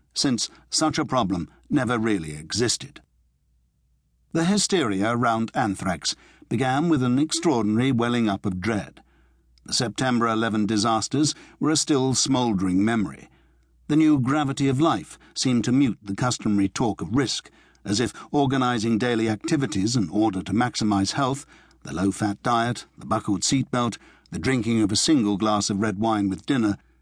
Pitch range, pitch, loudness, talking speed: 100-130 Hz, 115 Hz, -23 LUFS, 155 wpm